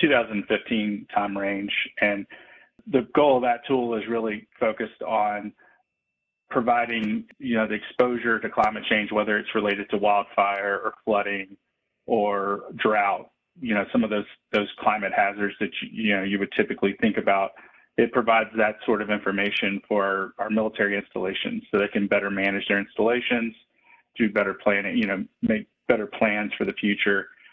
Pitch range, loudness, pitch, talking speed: 100-115 Hz, -24 LUFS, 105 Hz, 165 wpm